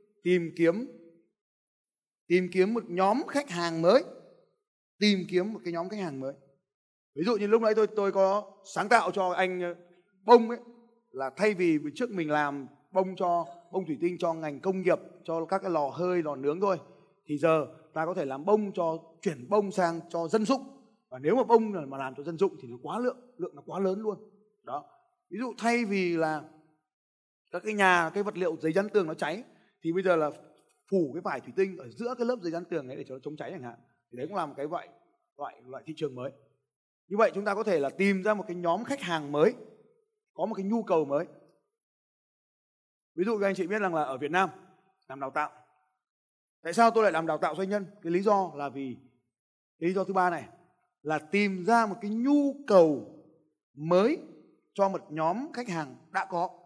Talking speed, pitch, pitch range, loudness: 220 wpm, 185 Hz, 160-210 Hz, -29 LUFS